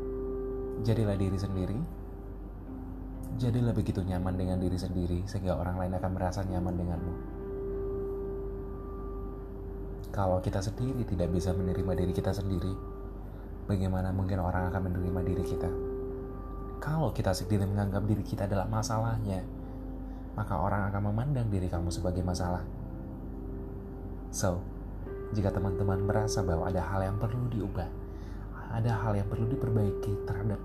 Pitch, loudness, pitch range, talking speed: 95 Hz, -33 LUFS, 90-100 Hz, 125 wpm